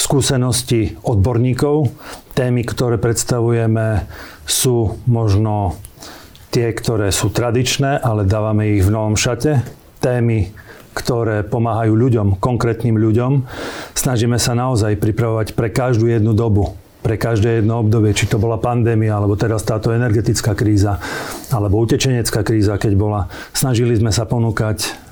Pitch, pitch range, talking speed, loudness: 115 Hz, 105-120 Hz, 125 wpm, -17 LUFS